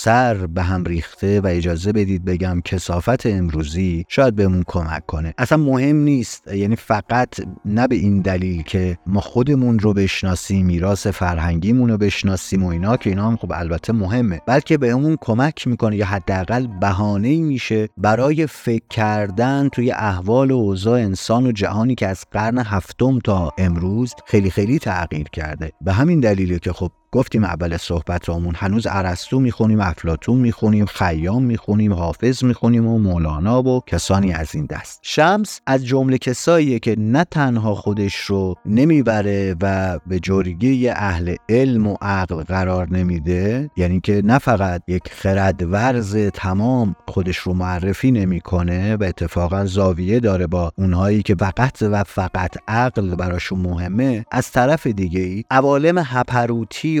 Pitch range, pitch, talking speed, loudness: 90-120 Hz, 100 Hz, 150 wpm, -18 LUFS